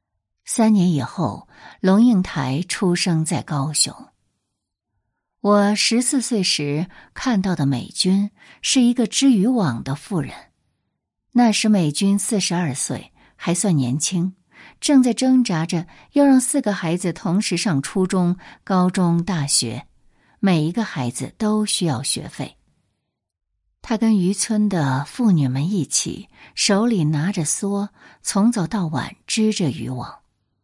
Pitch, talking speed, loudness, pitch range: 180 Hz, 190 characters per minute, -20 LUFS, 145-210 Hz